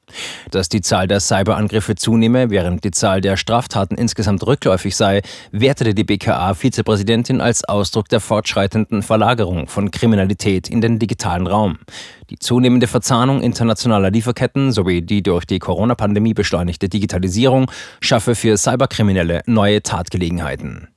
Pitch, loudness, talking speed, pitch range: 110 Hz, -16 LUFS, 130 wpm, 100-115 Hz